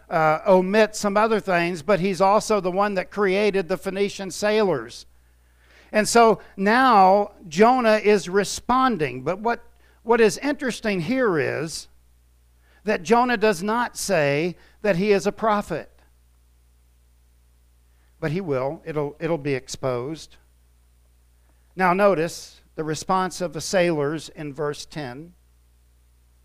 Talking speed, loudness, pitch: 125 wpm, -22 LUFS, 170 Hz